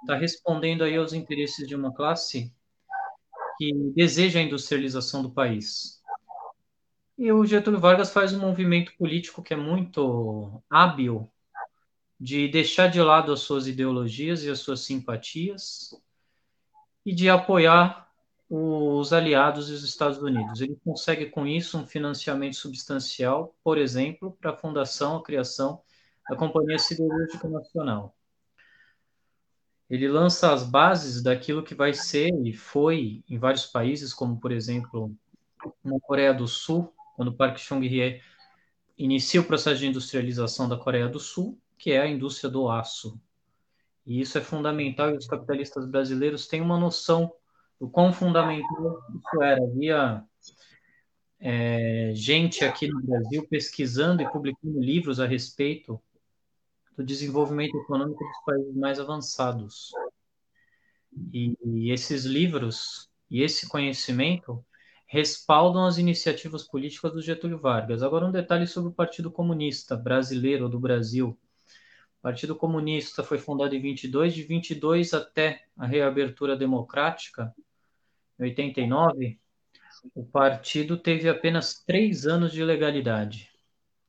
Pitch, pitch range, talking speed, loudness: 145 Hz, 130-165 Hz, 130 wpm, -25 LUFS